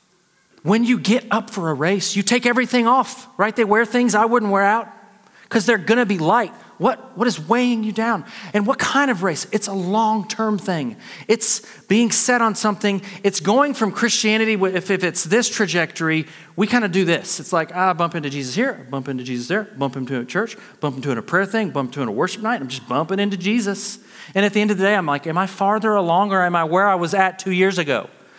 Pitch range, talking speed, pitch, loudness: 180-225 Hz, 240 wpm, 205 Hz, -19 LUFS